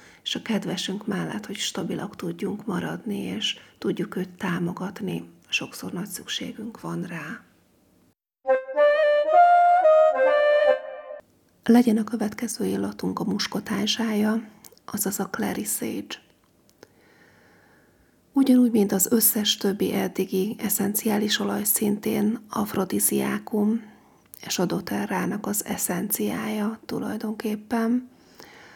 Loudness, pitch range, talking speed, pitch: -24 LUFS, 195-235 Hz, 90 wpm, 215 Hz